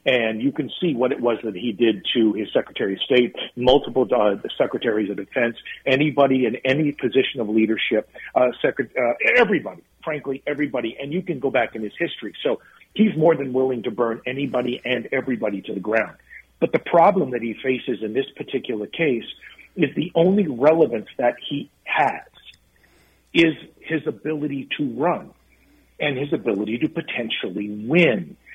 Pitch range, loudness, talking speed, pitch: 115-155 Hz, -22 LUFS, 170 wpm, 130 Hz